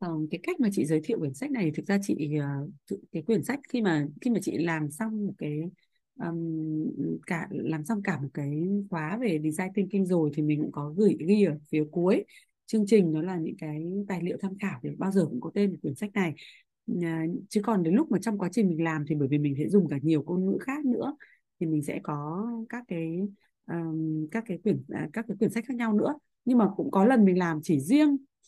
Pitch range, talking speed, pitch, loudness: 155-220 Hz, 240 wpm, 185 Hz, -28 LUFS